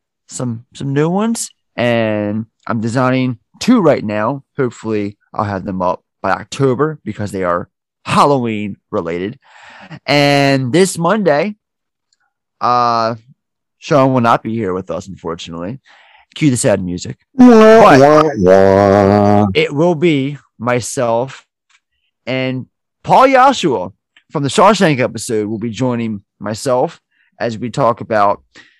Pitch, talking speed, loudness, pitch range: 120 Hz, 120 wpm, -14 LUFS, 105-140 Hz